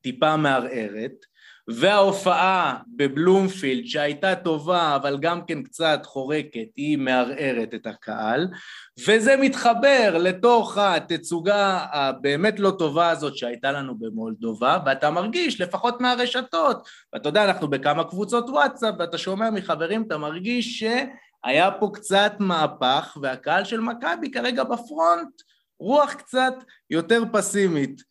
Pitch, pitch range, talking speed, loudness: 175 Hz, 145-220 Hz, 115 wpm, -22 LUFS